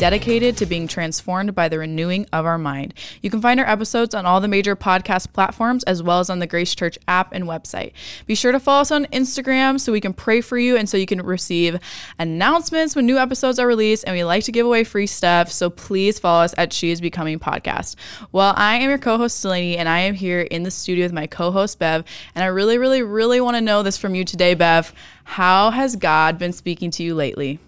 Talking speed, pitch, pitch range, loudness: 245 wpm, 190 Hz, 170-230 Hz, -18 LUFS